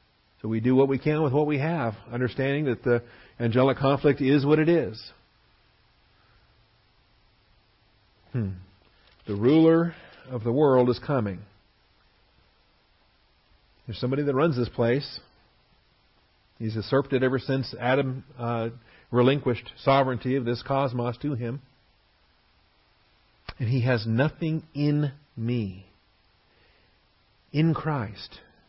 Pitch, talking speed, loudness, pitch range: 125 Hz, 115 wpm, -25 LUFS, 110-140 Hz